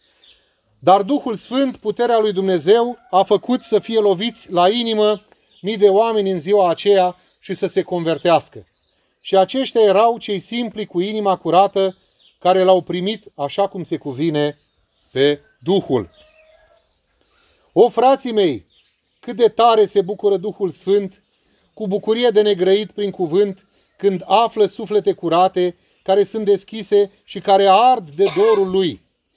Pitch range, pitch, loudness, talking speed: 185-220 Hz, 200 Hz, -17 LUFS, 140 wpm